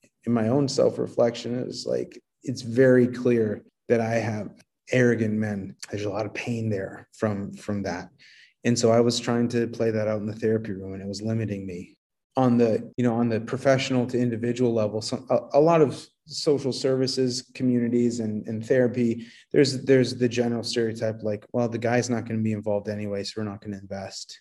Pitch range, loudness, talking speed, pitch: 110-125 Hz, -25 LUFS, 205 wpm, 115 Hz